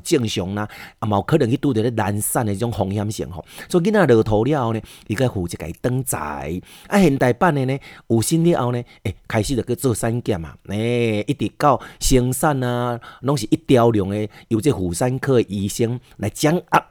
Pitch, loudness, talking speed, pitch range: 120 Hz, -20 LUFS, 300 characters per minute, 105-140 Hz